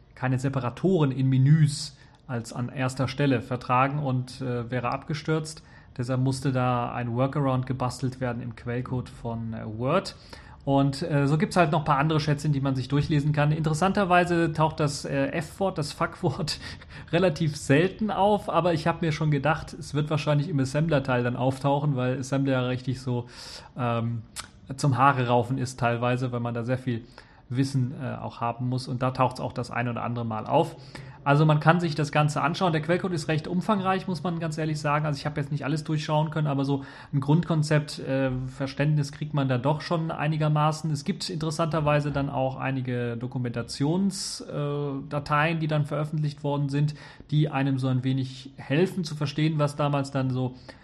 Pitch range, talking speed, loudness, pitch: 130-155 Hz, 185 wpm, -26 LUFS, 140 Hz